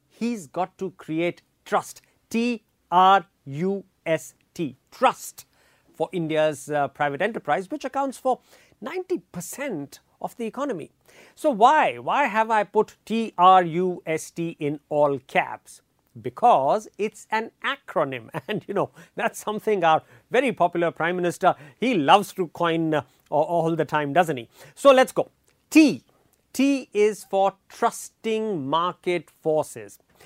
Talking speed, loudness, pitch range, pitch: 140 wpm, -23 LUFS, 160-220 Hz, 180 Hz